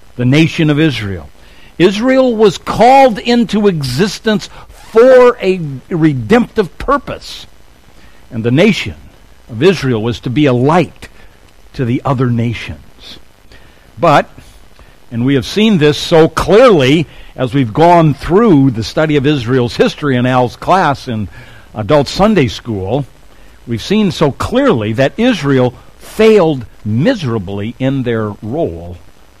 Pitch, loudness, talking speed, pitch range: 135 Hz, -11 LUFS, 125 wpm, 115-175 Hz